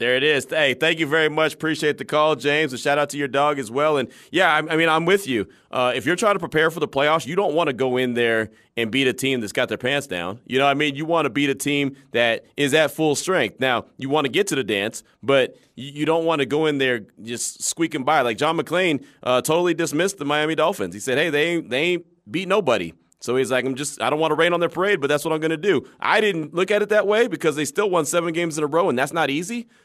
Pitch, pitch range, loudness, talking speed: 150 Hz, 135-165 Hz, -21 LUFS, 290 wpm